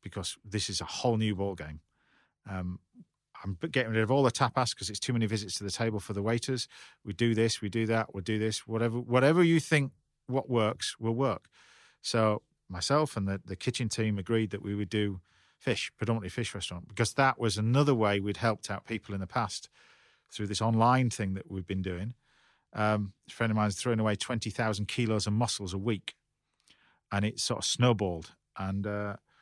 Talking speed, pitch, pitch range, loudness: 210 wpm, 110 Hz, 100-120 Hz, -31 LUFS